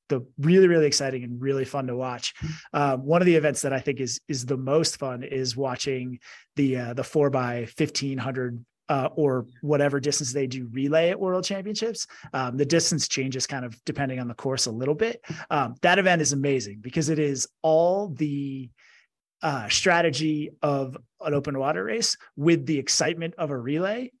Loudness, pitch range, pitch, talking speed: -25 LUFS, 130-160 Hz, 145 Hz, 190 wpm